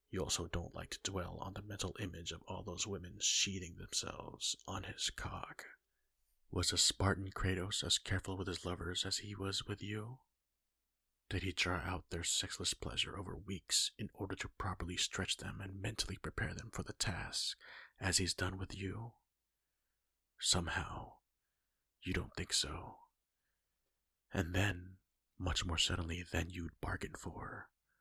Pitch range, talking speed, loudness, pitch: 90-100 Hz, 160 wpm, -39 LUFS, 95 Hz